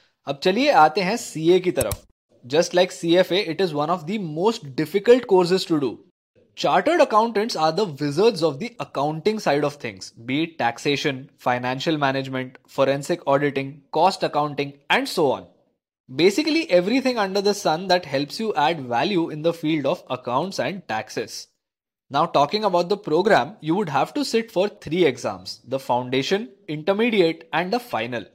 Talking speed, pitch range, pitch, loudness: 170 wpm, 145-205 Hz, 175 Hz, -22 LUFS